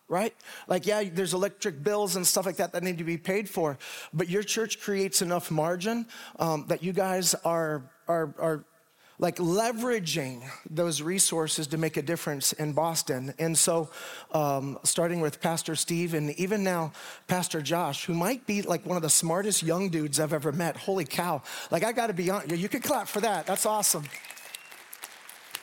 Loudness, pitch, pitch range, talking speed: -28 LUFS, 175 Hz, 160-195 Hz, 185 wpm